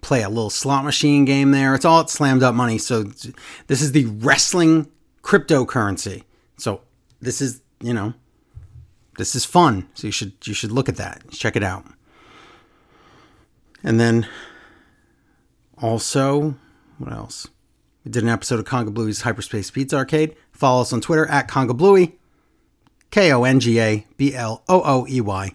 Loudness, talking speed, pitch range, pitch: -19 LUFS, 145 wpm, 115-140 Hz, 125 Hz